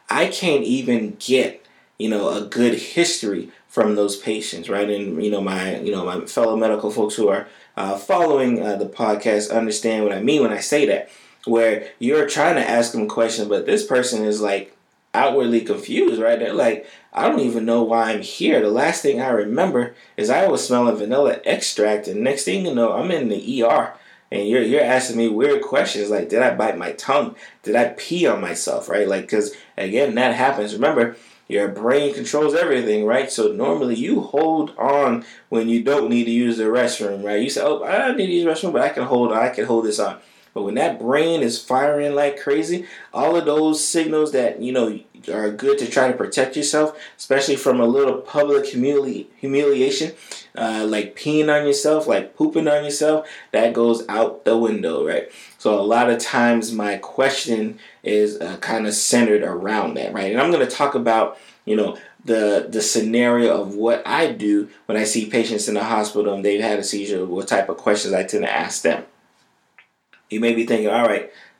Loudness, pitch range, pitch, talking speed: -20 LUFS, 105-140 Hz, 115 Hz, 205 wpm